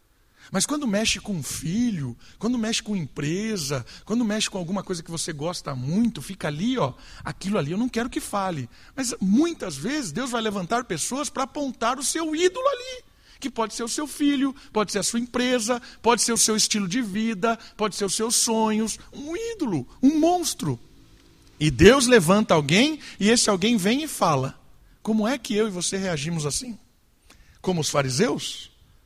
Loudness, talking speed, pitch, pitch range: -24 LUFS, 185 wpm, 220 Hz, 185-250 Hz